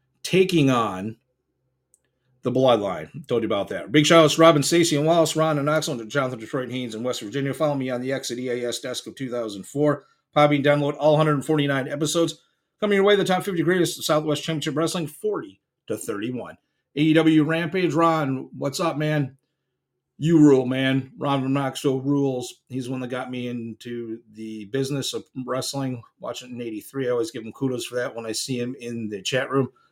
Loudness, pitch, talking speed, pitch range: -23 LUFS, 135 Hz, 195 wpm, 125-155 Hz